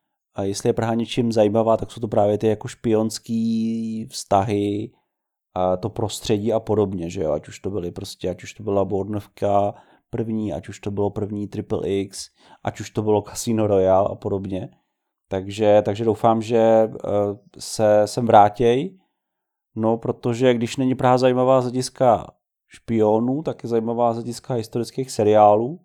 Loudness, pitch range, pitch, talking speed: -21 LUFS, 100-120 Hz, 110 Hz, 160 wpm